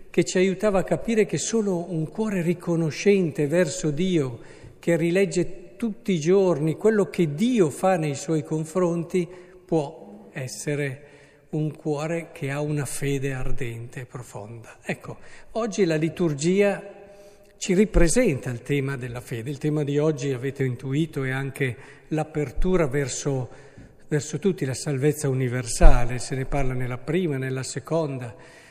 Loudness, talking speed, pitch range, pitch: -25 LUFS, 140 wpm, 140-180 Hz, 155 Hz